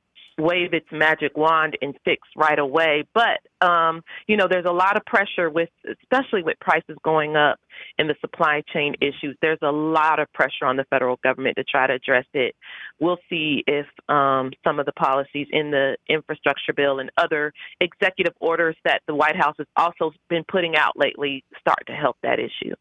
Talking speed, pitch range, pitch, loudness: 190 wpm, 145-170 Hz, 155 Hz, -21 LUFS